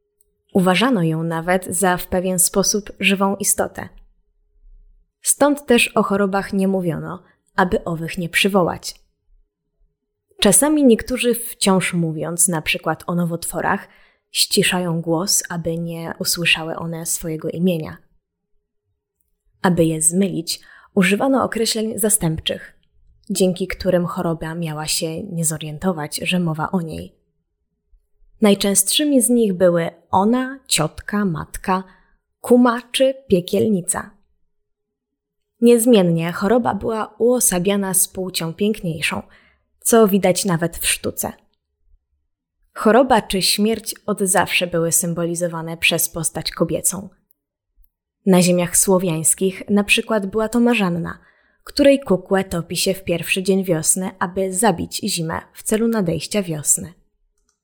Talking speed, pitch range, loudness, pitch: 110 wpm, 165-205 Hz, -18 LUFS, 185 Hz